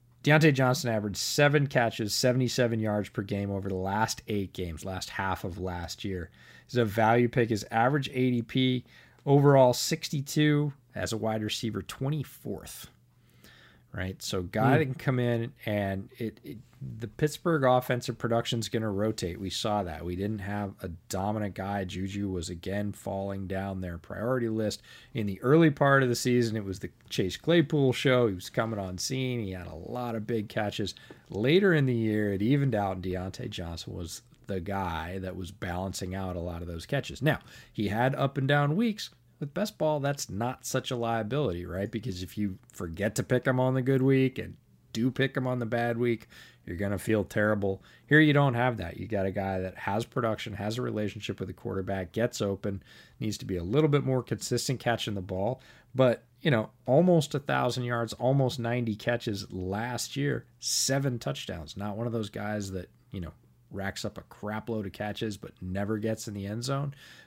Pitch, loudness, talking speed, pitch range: 110 Hz, -29 LUFS, 195 wpm, 100-125 Hz